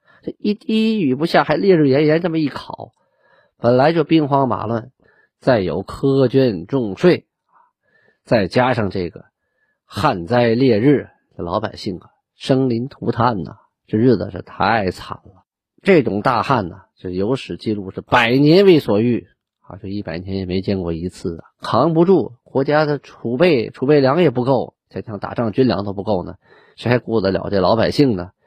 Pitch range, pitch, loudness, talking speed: 100-145 Hz, 120 Hz, -17 LUFS, 250 characters per minute